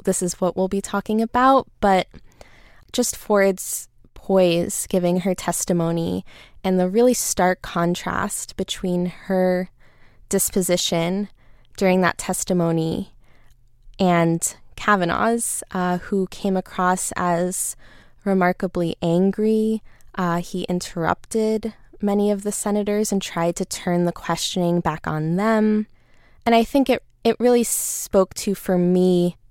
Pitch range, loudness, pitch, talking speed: 175-205 Hz, -21 LUFS, 185 Hz, 120 wpm